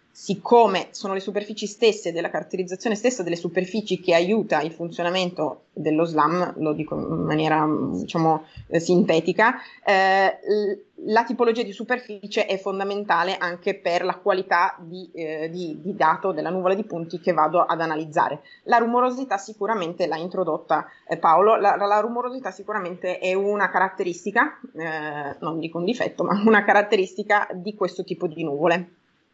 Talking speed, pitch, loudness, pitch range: 150 wpm, 185 Hz, -23 LUFS, 170-210 Hz